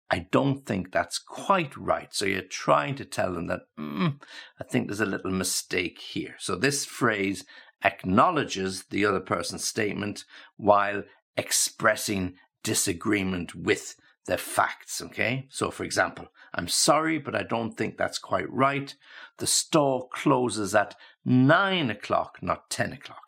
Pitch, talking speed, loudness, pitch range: 110 Hz, 145 wpm, -27 LUFS, 95-135 Hz